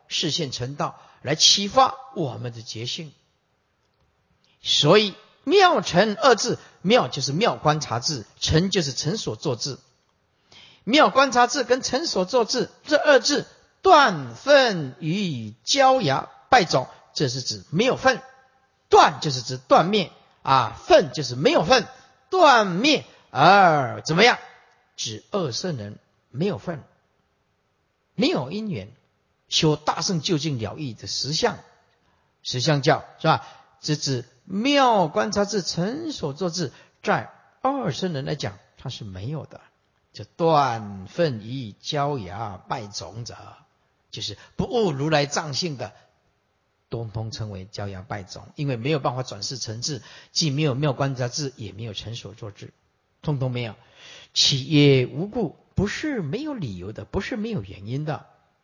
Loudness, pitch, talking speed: -22 LUFS, 150 Hz, 200 characters per minute